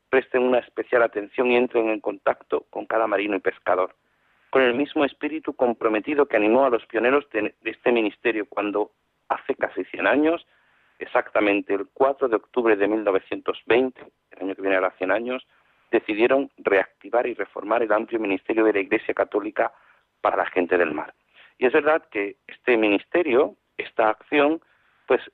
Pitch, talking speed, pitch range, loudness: 115 Hz, 165 wpm, 100-135 Hz, -23 LUFS